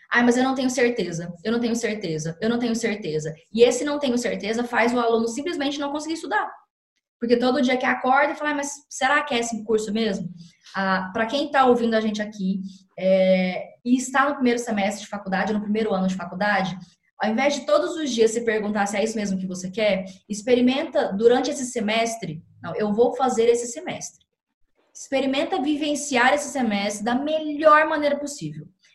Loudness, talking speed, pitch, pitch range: -22 LUFS, 195 wpm, 230 Hz, 200-270 Hz